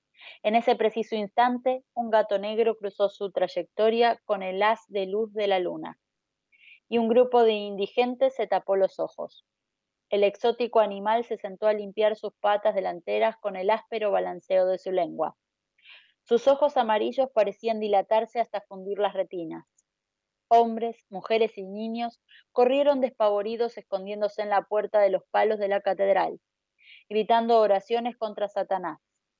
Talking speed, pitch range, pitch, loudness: 150 wpm, 200-230 Hz, 215 Hz, -26 LUFS